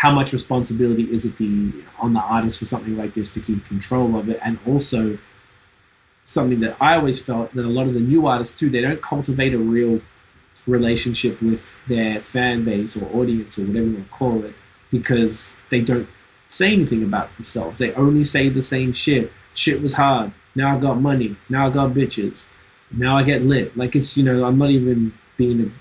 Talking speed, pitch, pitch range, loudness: 205 wpm, 120 Hz, 110-130 Hz, -19 LUFS